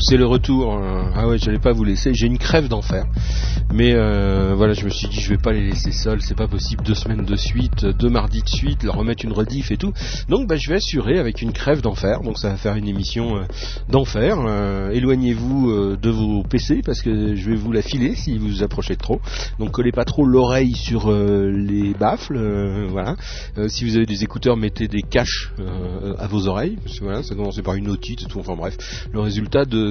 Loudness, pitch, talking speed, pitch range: -20 LUFS, 105 Hz, 235 wpm, 100-115 Hz